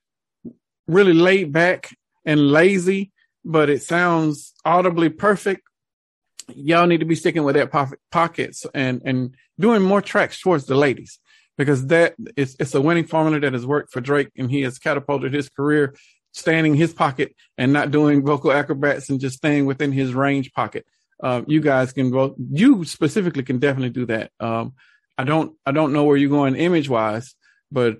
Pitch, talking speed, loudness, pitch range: 145 Hz, 180 wpm, -19 LUFS, 135-165 Hz